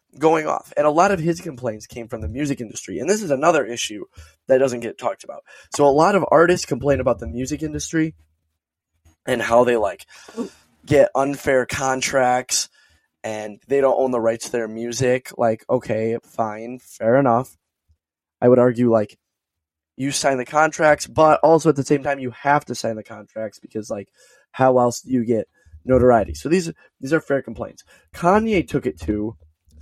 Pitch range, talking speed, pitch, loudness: 110-145 Hz, 185 wpm, 125 Hz, -20 LUFS